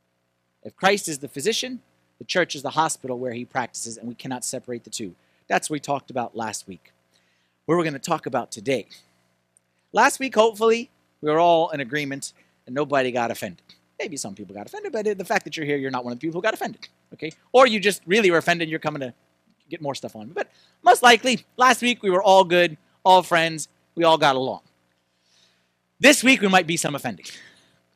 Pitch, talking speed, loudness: 140 Hz, 215 wpm, -21 LUFS